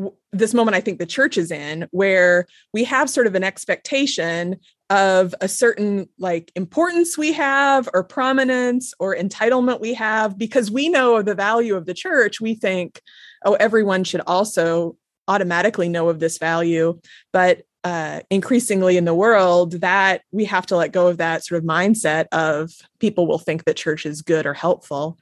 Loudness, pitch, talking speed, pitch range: -19 LUFS, 190 Hz, 180 wpm, 170-225 Hz